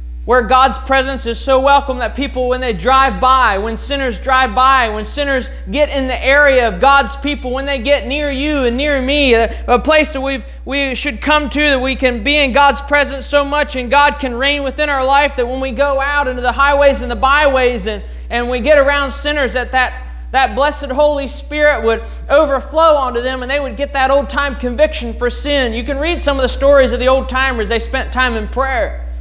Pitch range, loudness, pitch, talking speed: 255-285 Hz, -14 LUFS, 270 Hz, 230 wpm